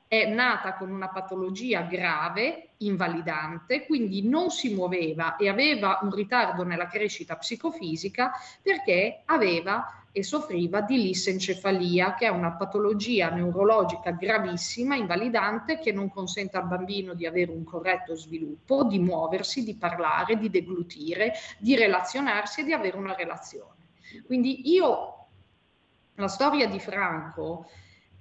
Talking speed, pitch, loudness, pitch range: 130 wpm, 195 Hz, -27 LUFS, 180-240 Hz